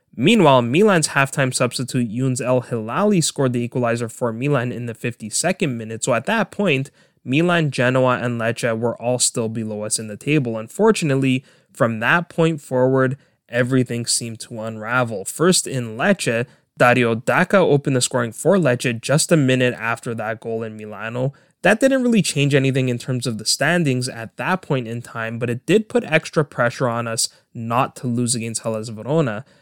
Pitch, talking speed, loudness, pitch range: 125 Hz, 180 wpm, -19 LUFS, 115-150 Hz